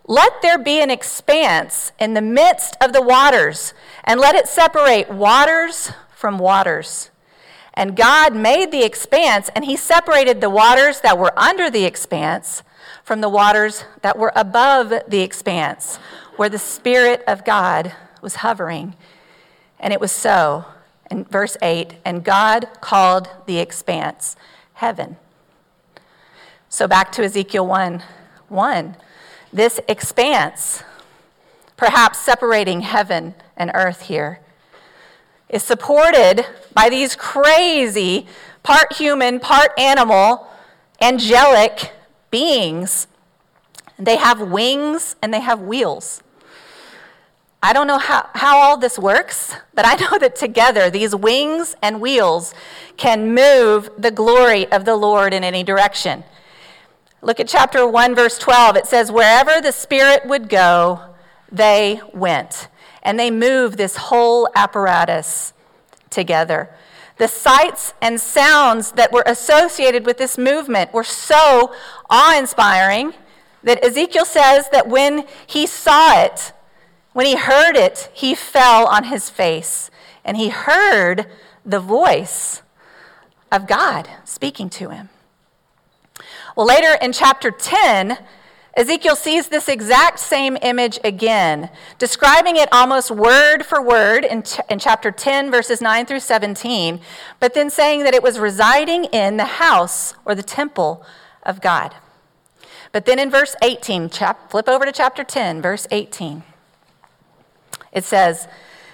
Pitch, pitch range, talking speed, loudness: 235 Hz, 205-280 Hz, 130 wpm, -14 LUFS